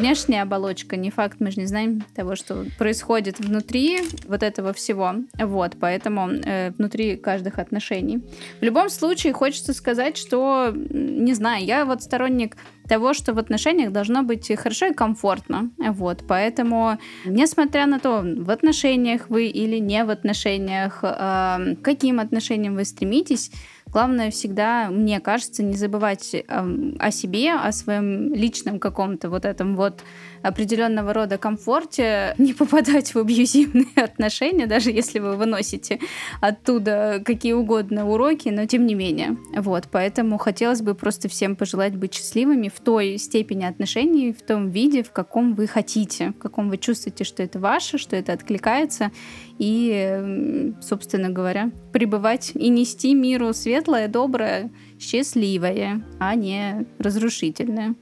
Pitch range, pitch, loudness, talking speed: 200-250 Hz, 220 Hz, -22 LUFS, 140 wpm